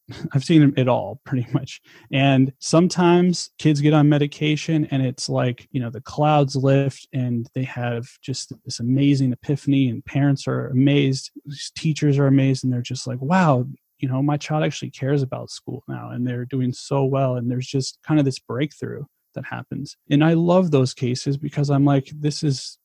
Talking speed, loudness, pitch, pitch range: 190 wpm, -21 LUFS, 135 Hz, 130-150 Hz